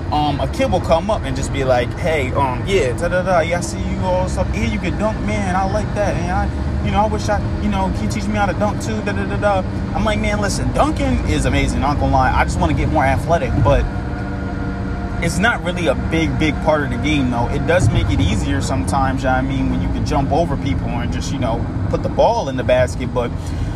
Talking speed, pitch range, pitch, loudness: 260 wpm, 95-105 Hz, 100 Hz, -18 LUFS